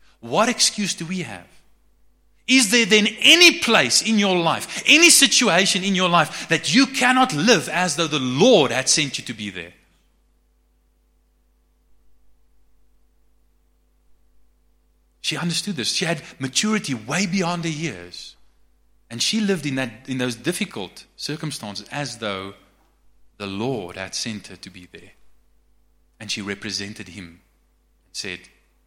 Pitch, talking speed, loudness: 115 Hz, 140 wpm, -18 LUFS